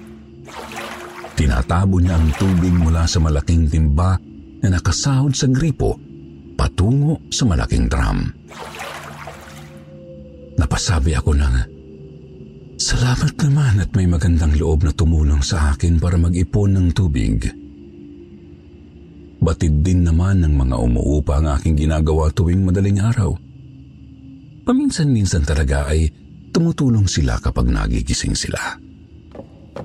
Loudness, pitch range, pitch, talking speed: -18 LUFS, 75-95 Hz, 80 Hz, 105 wpm